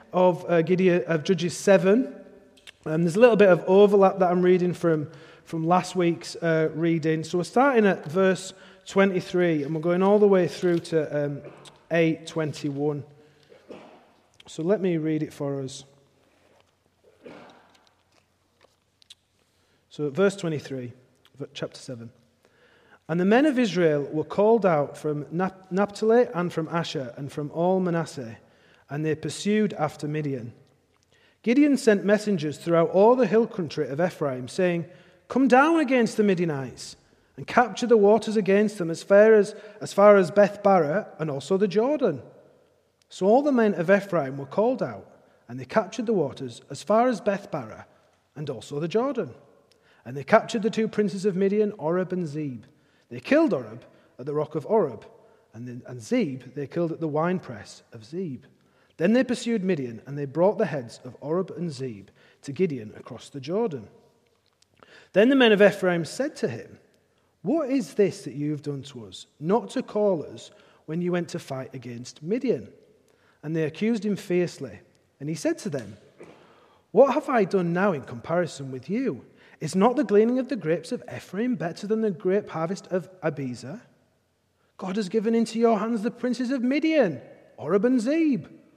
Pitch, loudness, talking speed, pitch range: 180 Hz, -24 LUFS, 170 wpm, 150-210 Hz